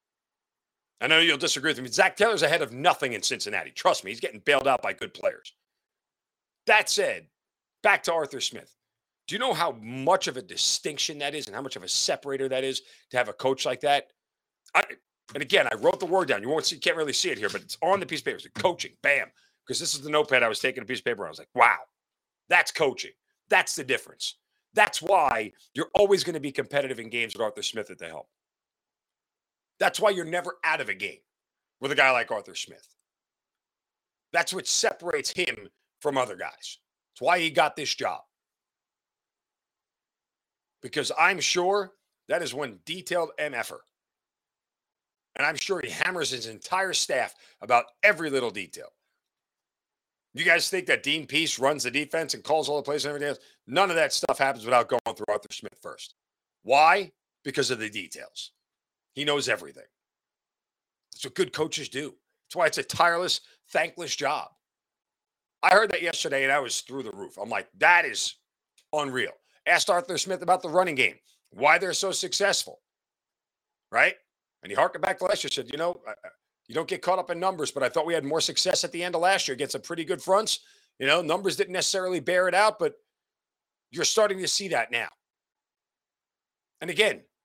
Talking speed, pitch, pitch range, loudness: 200 wpm, 170 Hz, 145-190 Hz, -25 LUFS